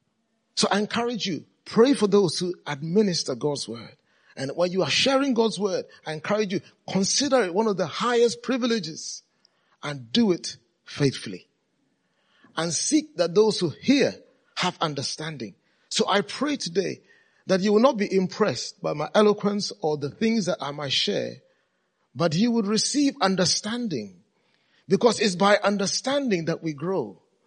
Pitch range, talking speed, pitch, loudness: 170-225 Hz, 155 wpm, 200 Hz, -24 LUFS